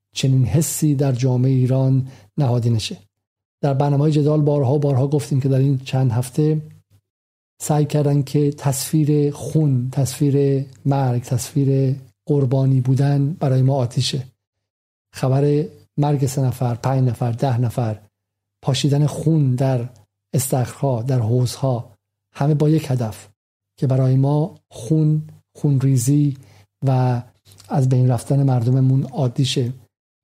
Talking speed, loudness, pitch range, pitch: 120 wpm, -19 LUFS, 120-145 Hz, 135 Hz